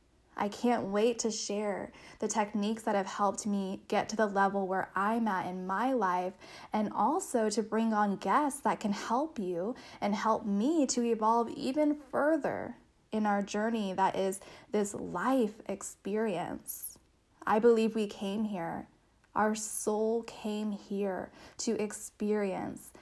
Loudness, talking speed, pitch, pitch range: -32 LUFS, 150 wpm, 215 Hz, 200-230 Hz